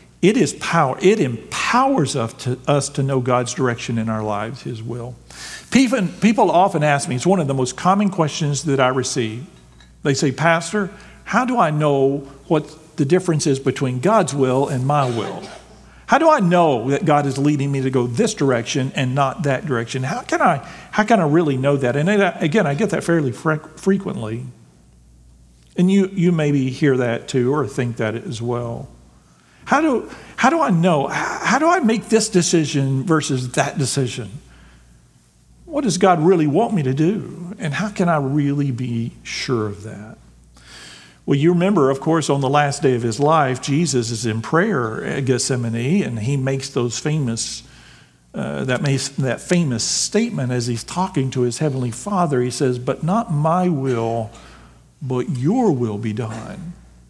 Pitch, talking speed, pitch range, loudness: 140 Hz, 180 wpm, 120-170 Hz, -19 LUFS